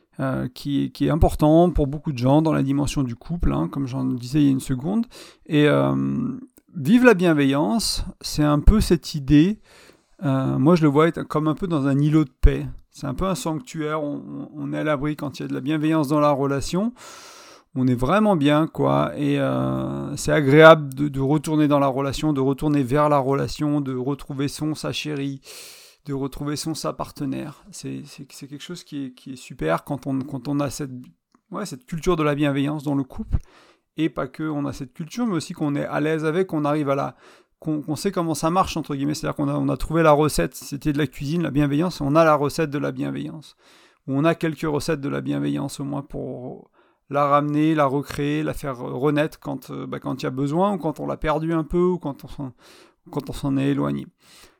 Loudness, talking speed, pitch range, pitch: -22 LUFS, 235 wpm, 140-160 Hz, 150 Hz